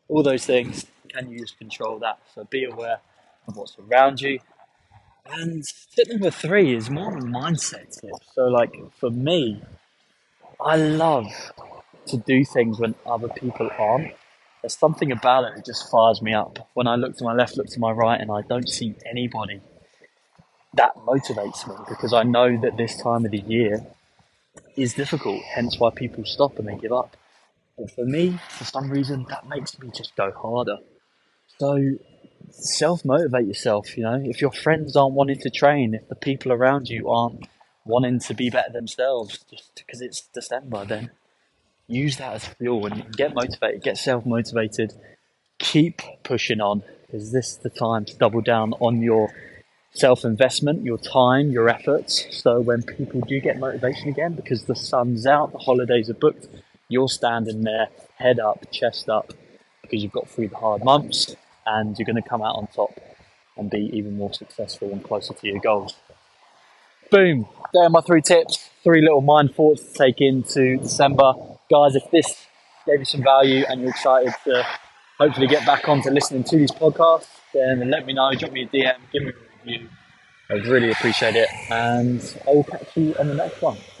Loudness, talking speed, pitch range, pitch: -21 LUFS, 180 wpm, 115-140 Hz, 125 Hz